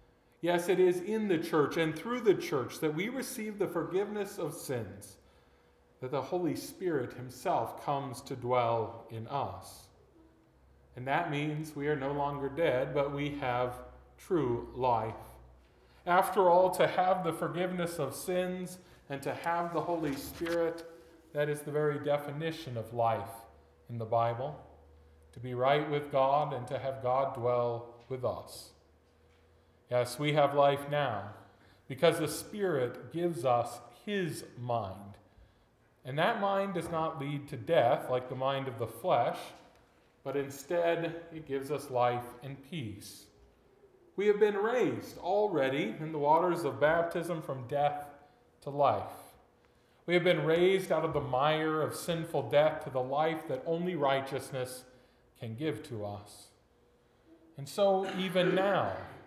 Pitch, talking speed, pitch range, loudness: 140 Hz, 150 wpm, 120-165 Hz, -32 LUFS